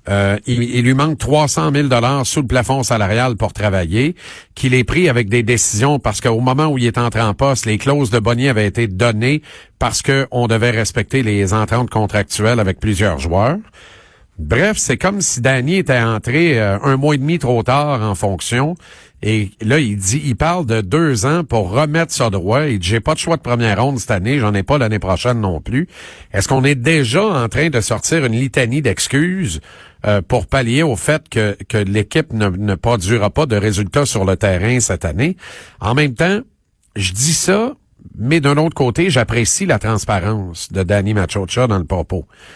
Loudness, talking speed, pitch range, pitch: -15 LUFS, 200 wpm, 105-145 Hz, 120 Hz